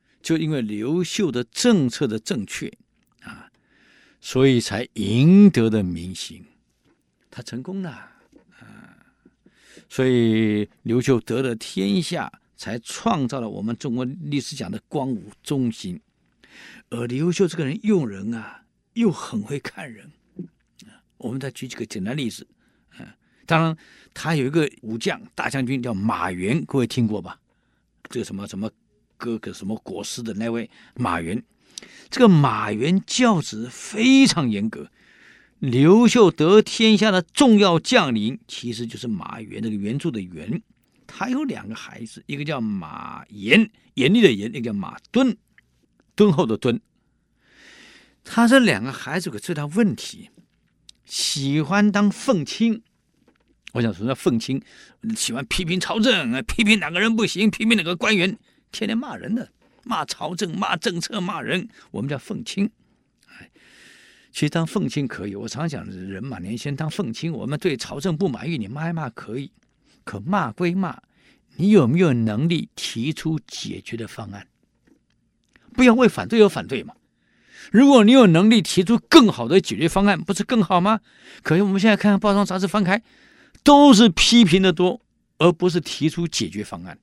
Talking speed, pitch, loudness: 230 characters per minute, 175 Hz, -20 LUFS